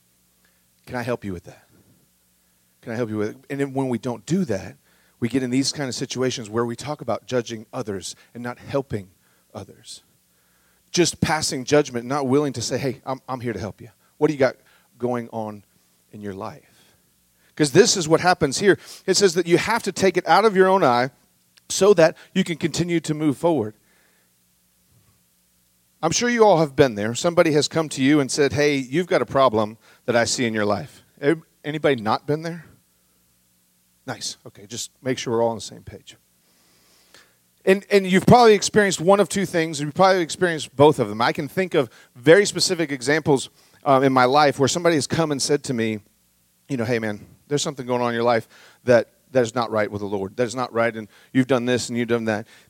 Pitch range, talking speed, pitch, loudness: 110-155 Hz, 215 wpm, 130 Hz, -21 LUFS